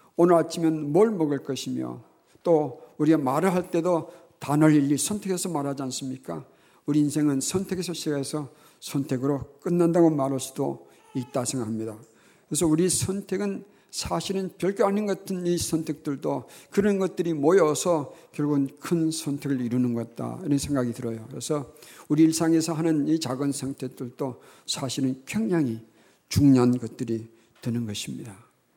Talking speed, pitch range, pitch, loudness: 330 characters per minute, 130-170 Hz, 150 Hz, -26 LUFS